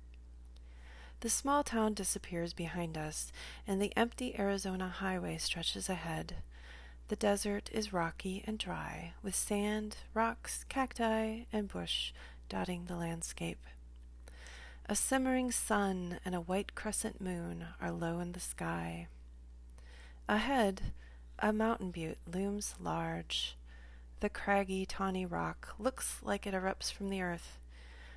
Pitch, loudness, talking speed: 180 Hz, -37 LUFS, 125 wpm